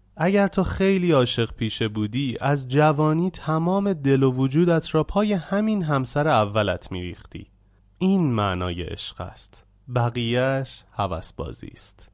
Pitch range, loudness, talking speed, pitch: 100-160 Hz, -23 LUFS, 125 wpm, 130 Hz